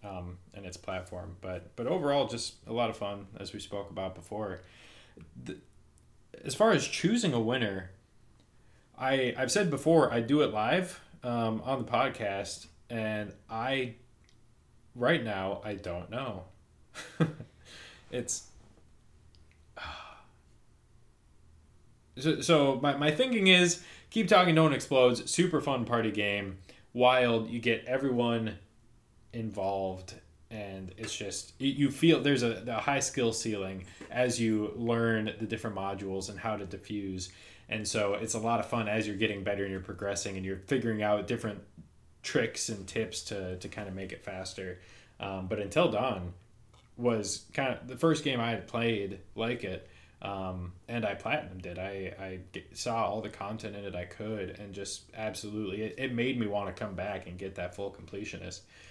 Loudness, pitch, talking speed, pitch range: -31 LUFS, 105 Hz, 165 wpm, 95-120 Hz